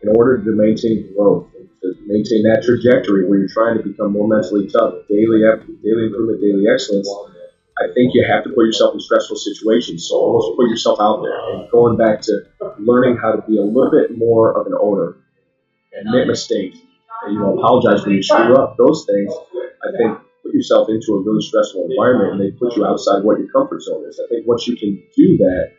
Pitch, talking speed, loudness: 110 Hz, 215 wpm, -15 LUFS